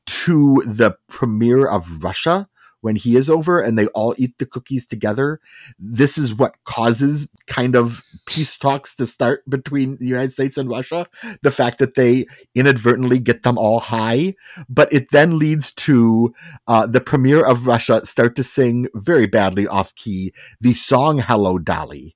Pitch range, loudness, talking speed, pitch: 115-140 Hz, -17 LUFS, 170 wpm, 125 Hz